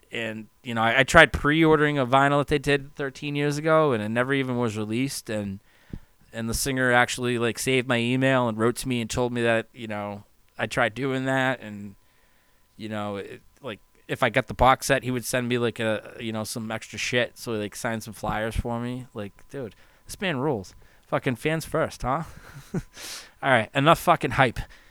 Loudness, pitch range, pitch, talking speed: -24 LUFS, 110-135 Hz, 120 Hz, 215 wpm